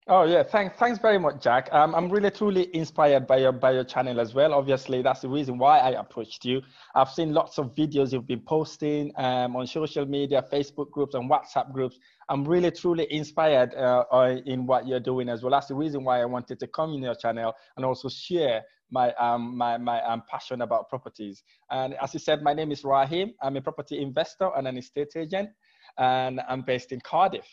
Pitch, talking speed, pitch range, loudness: 135 Hz, 215 wpm, 125-155 Hz, -26 LUFS